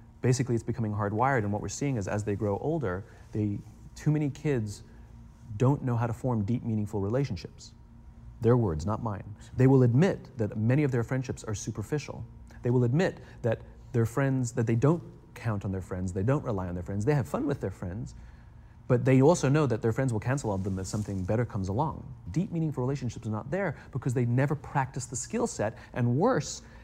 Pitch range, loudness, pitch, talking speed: 105-135 Hz, -29 LUFS, 120 Hz, 210 wpm